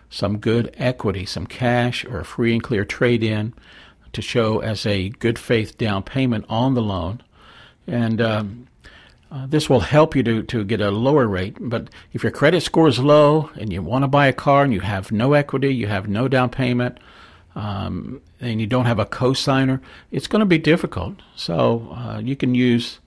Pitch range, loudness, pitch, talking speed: 110-135 Hz, -20 LUFS, 120 Hz, 200 wpm